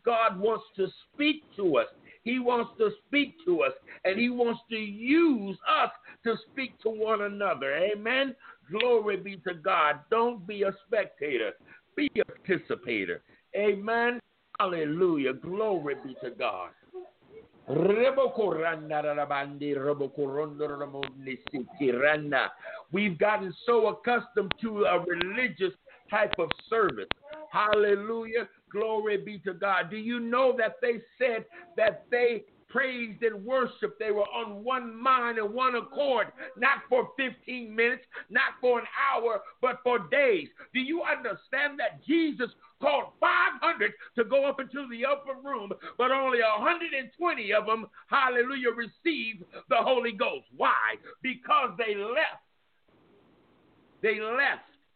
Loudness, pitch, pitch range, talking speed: -28 LUFS, 235 Hz, 210-270 Hz, 125 wpm